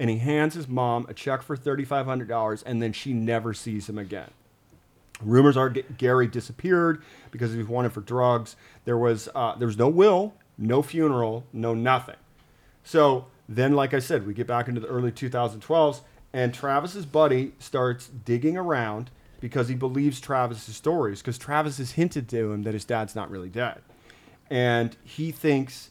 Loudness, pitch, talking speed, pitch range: -25 LUFS, 125 Hz, 175 wpm, 115-140 Hz